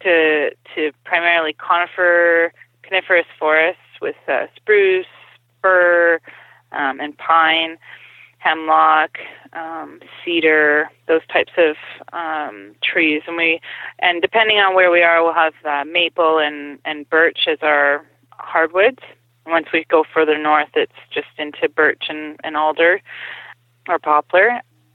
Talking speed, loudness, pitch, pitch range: 130 wpm, -16 LUFS, 160 Hz, 150-175 Hz